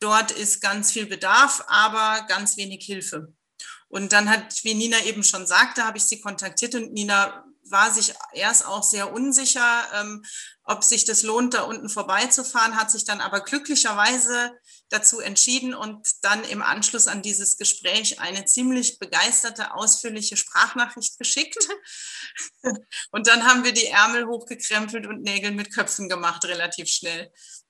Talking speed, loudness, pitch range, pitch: 155 wpm, -20 LUFS, 205-240 Hz, 220 Hz